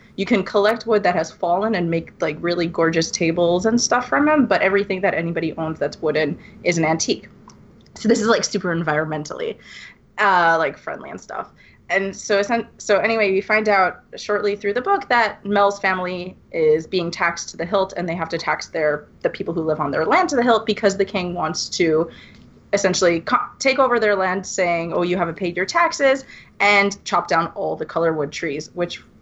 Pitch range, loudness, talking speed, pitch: 165-210 Hz, -20 LUFS, 205 wpm, 185 Hz